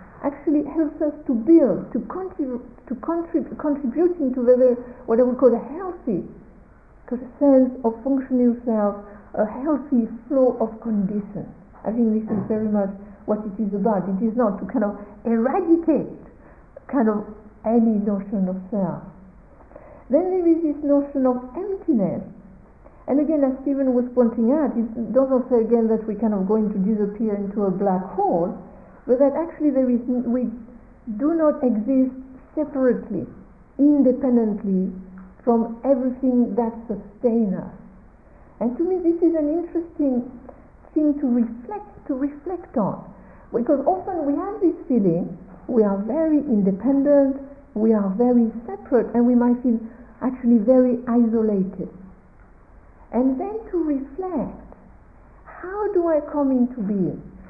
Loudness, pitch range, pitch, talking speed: -21 LUFS, 215-285 Hz, 245 Hz, 145 wpm